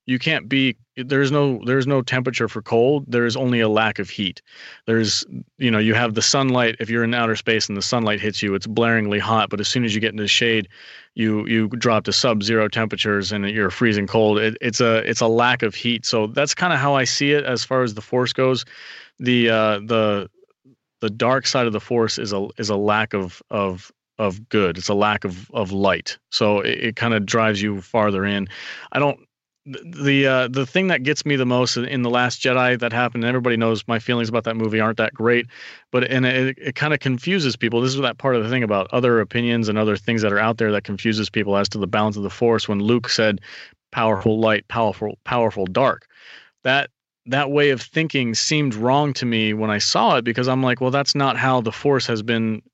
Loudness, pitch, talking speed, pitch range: -20 LUFS, 115 Hz, 235 wpm, 110-130 Hz